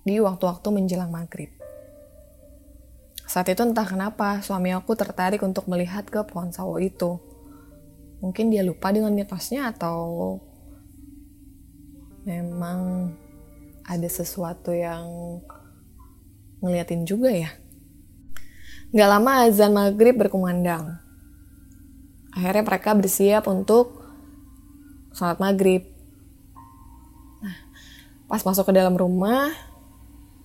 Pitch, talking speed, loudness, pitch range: 180 Hz, 95 wpm, -23 LUFS, 145-205 Hz